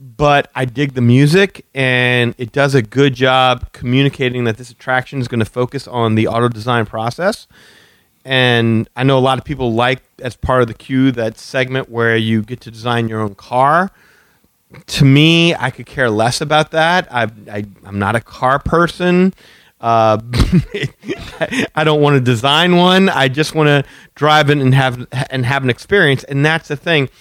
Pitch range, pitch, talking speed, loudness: 120-145 Hz, 130 Hz, 185 wpm, -14 LUFS